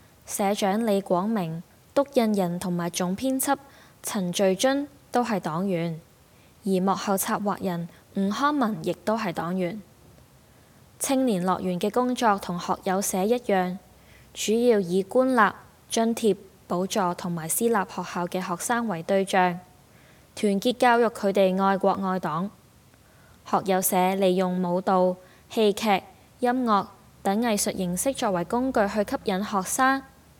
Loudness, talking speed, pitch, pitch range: -25 LUFS, 205 characters per minute, 195 Hz, 185-225 Hz